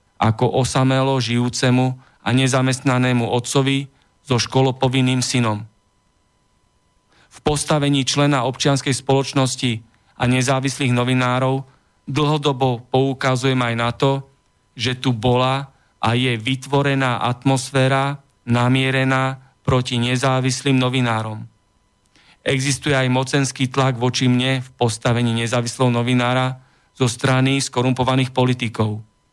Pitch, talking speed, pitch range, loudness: 130 Hz, 95 wpm, 120-135 Hz, -19 LUFS